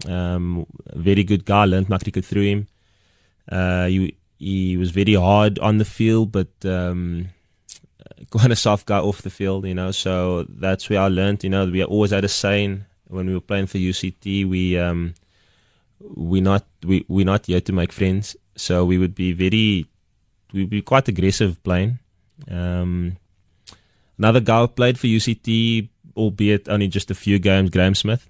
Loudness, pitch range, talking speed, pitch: -20 LUFS, 90-105 Hz, 175 wpm, 95 Hz